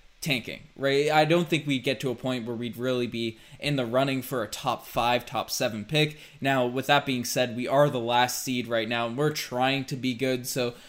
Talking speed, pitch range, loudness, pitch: 235 wpm, 120-140 Hz, -27 LUFS, 130 Hz